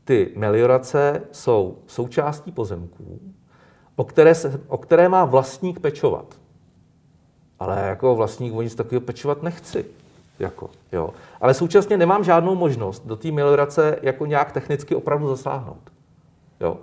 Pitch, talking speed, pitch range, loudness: 145 Hz, 130 wpm, 125-170 Hz, -20 LUFS